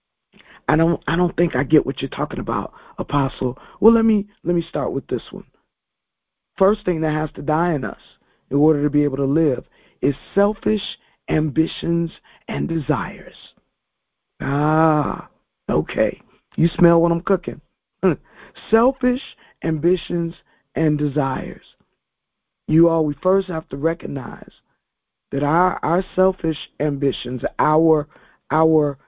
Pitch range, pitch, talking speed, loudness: 145-175 Hz, 160 Hz, 135 wpm, -20 LUFS